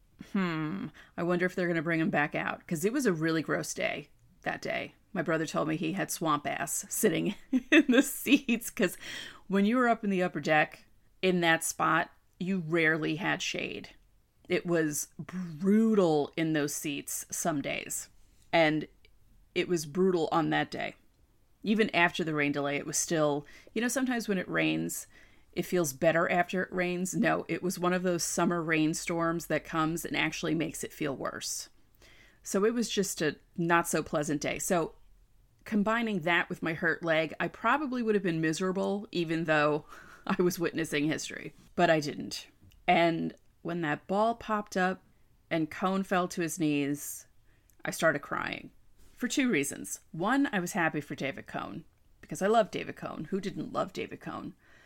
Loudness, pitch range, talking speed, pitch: -30 LUFS, 155-195 Hz, 180 wpm, 170 Hz